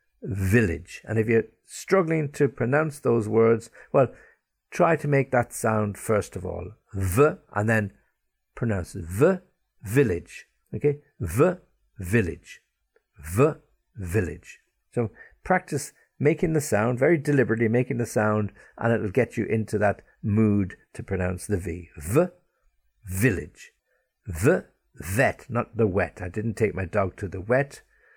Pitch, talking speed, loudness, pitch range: 115 Hz, 140 wpm, -25 LUFS, 100-140 Hz